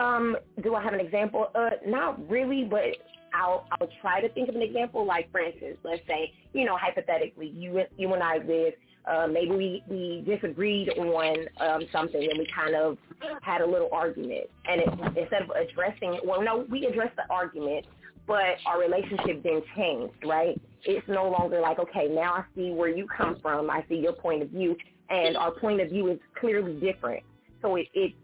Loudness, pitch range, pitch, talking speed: -28 LUFS, 165-215 Hz, 180 Hz, 200 wpm